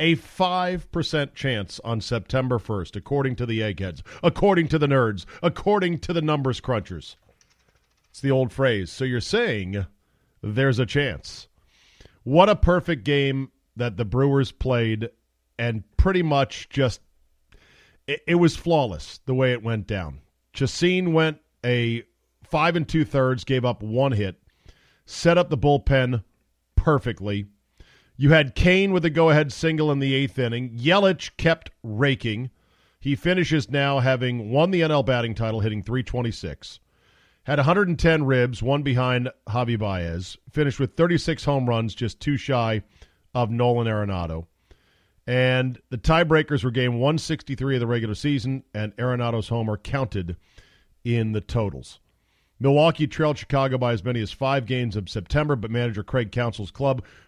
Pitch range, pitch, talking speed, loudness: 110-145 Hz, 125 Hz, 150 wpm, -23 LUFS